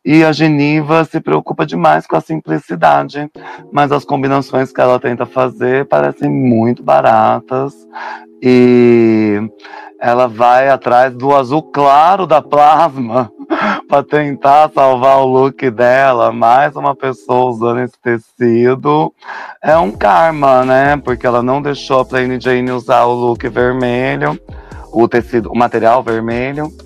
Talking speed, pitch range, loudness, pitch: 130 wpm, 120-140 Hz, -12 LUFS, 130 Hz